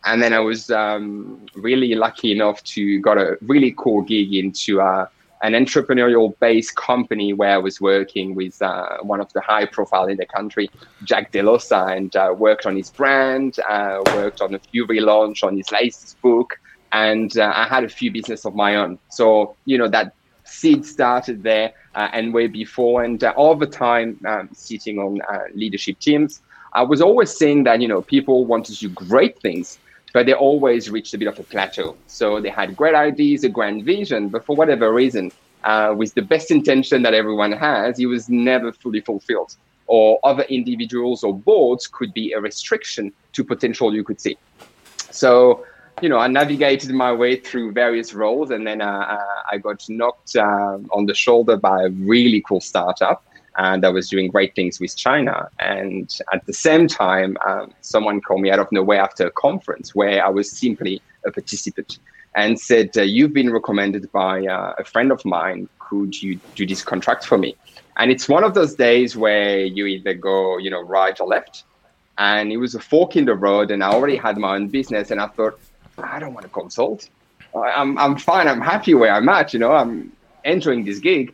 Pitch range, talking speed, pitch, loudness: 100-125 Hz, 200 wpm, 110 Hz, -18 LUFS